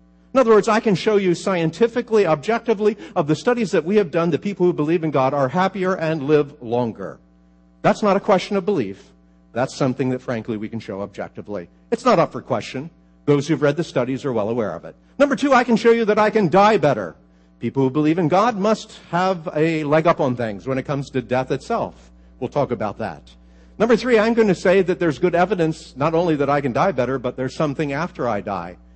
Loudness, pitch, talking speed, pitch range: -20 LUFS, 155 Hz, 230 wpm, 120-195 Hz